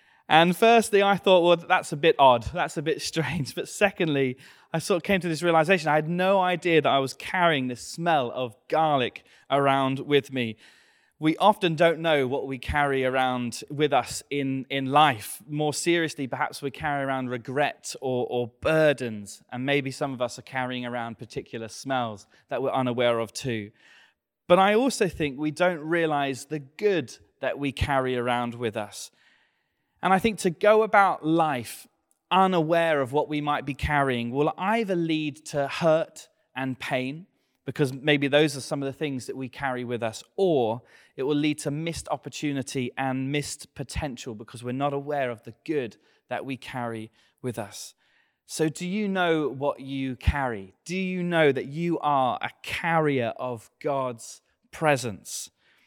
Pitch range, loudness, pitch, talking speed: 130-165 Hz, -25 LUFS, 145 Hz, 175 wpm